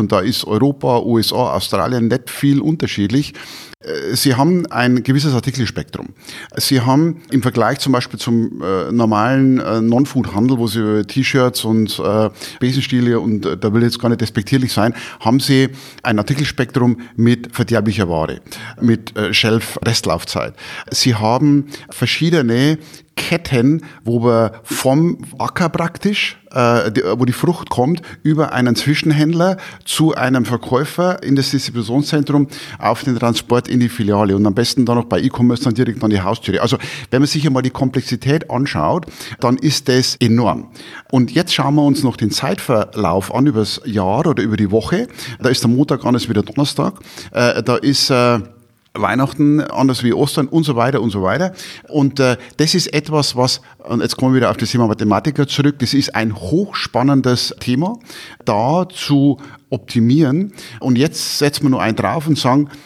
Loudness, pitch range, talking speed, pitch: -16 LUFS, 115-145 Hz, 165 wpm, 125 Hz